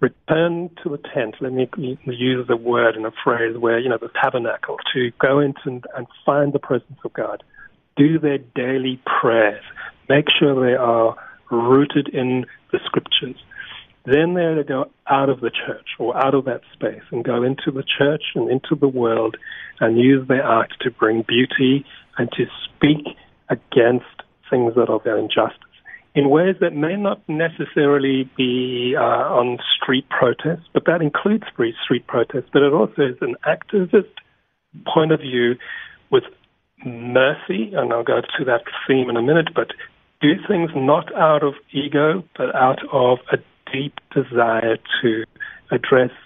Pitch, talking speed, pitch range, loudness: 135 Hz, 165 wpm, 125-155 Hz, -19 LUFS